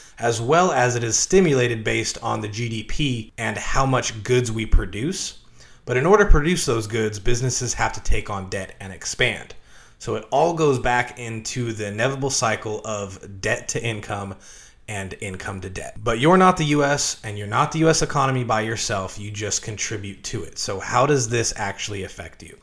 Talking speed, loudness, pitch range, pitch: 195 wpm, -22 LUFS, 105-135 Hz, 115 Hz